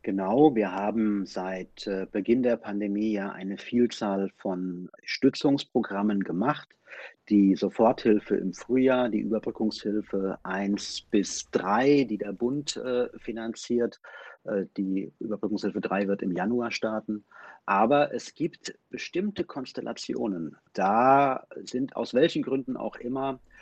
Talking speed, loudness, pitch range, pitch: 115 wpm, -27 LUFS, 100-125 Hz, 110 Hz